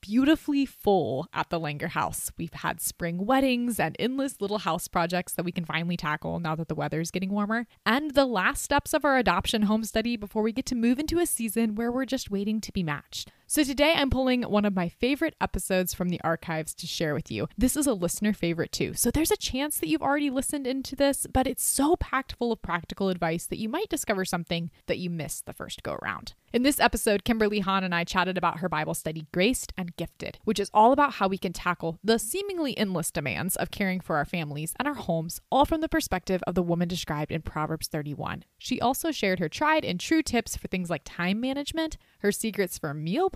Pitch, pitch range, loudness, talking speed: 205 Hz, 170-260 Hz, -27 LUFS, 230 wpm